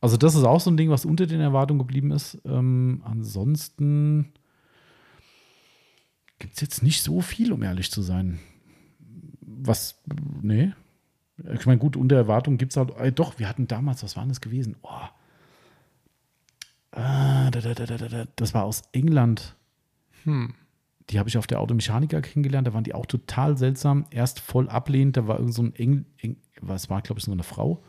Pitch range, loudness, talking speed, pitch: 115-145 Hz, -24 LUFS, 170 wpm, 130 Hz